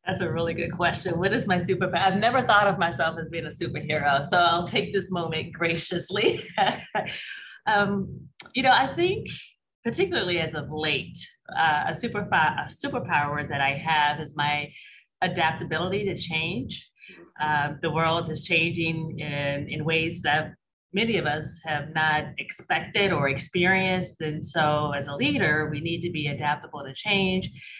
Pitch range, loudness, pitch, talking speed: 150-185 Hz, -25 LUFS, 165 Hz, 160 wpm